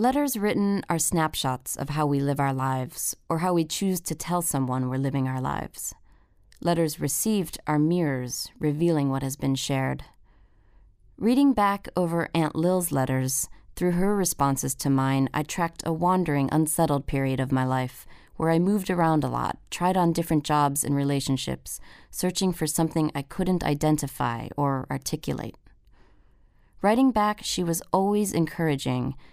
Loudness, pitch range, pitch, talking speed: -26 LUFS, 135-175 Hz, 150 Hz, 155 wpm